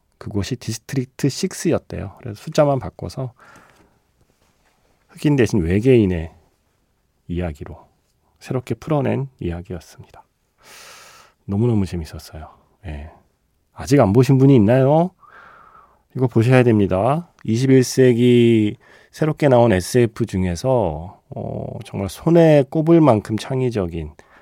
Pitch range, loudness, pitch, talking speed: 95-135 Hz, -18 LUFS, 120 Hz, 240 characters per minute